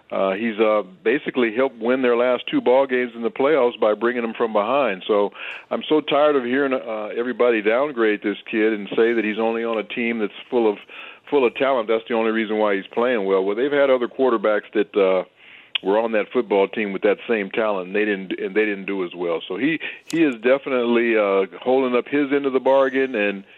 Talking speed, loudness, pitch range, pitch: 230 wpm, -21 LUFS, 105-130 Hz, 115 Hz